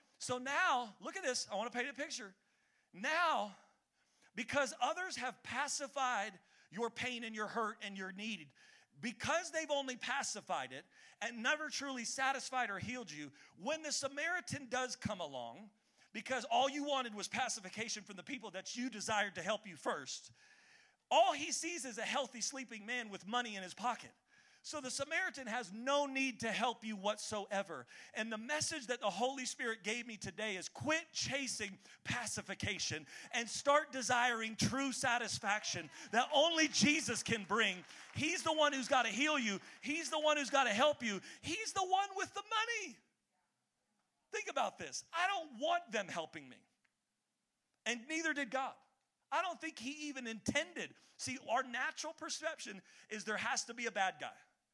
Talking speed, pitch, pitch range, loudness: 170 wpm, 250 Hz, 220-295 Hz, -38 LUFS